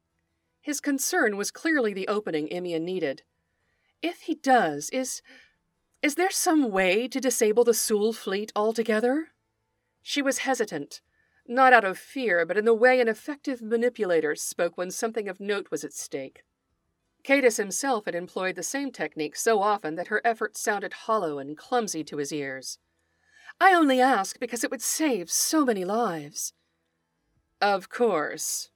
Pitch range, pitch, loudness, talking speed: 185-265 Hz, 225 Hz, -25 LUFS, 155 wpm